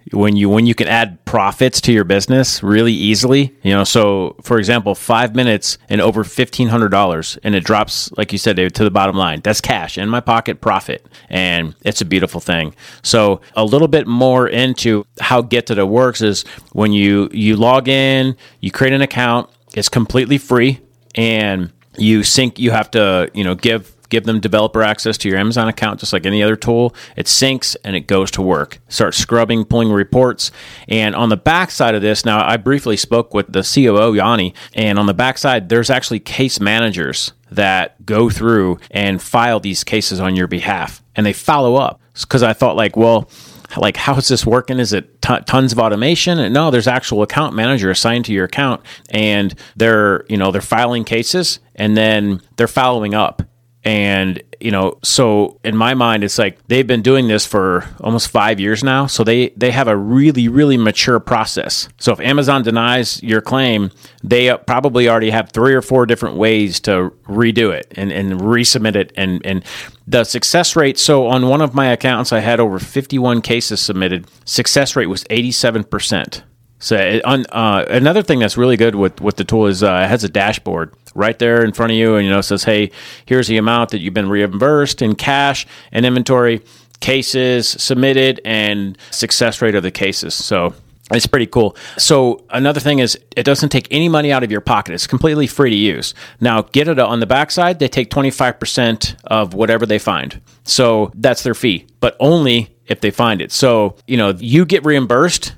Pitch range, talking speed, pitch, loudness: 105-125 Hz, 200 wpm, 115 Hz, -14 LUFS